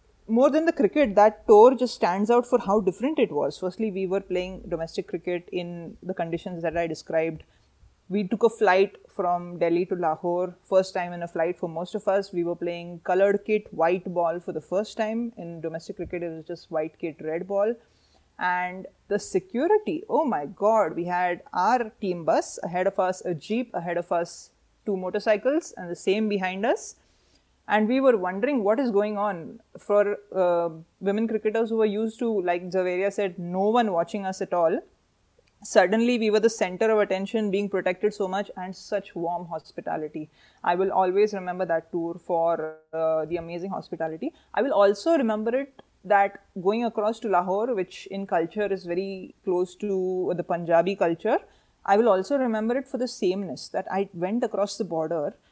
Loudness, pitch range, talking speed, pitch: -25 LUFS, 175-215 Hz, 190 wpm, 190 Hz